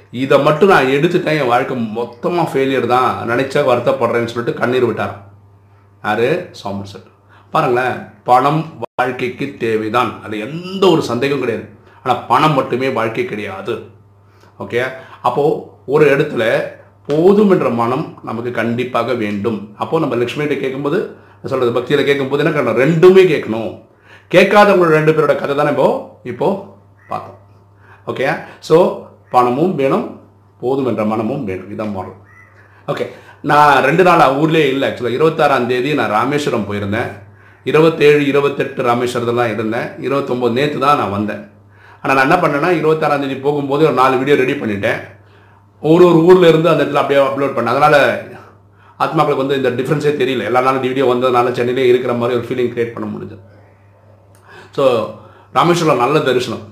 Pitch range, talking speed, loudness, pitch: 105-145 Hz, 145 wpm, -14 LUFS, 120 Hz